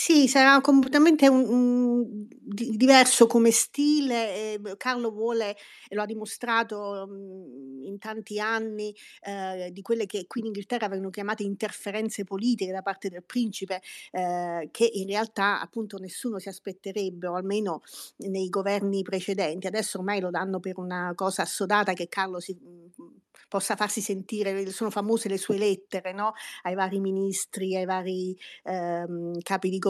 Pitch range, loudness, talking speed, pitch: 190-220 Hz, -26 LUFS, 150 wpm, 200 Hz